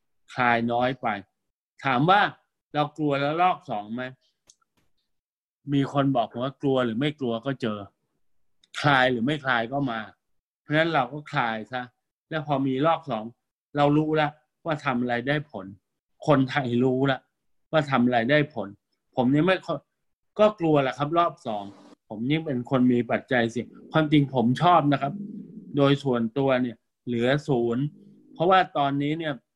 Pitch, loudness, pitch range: 140 Hz, -25 LUFS, 125-150 Hz